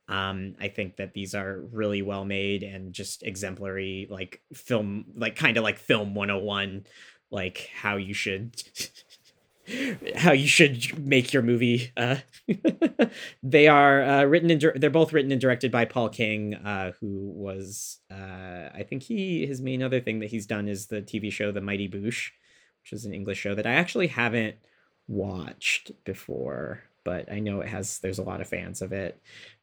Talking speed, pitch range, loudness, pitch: 180 wpm, 100-130 Hz, -26 LUFS, 105 Hz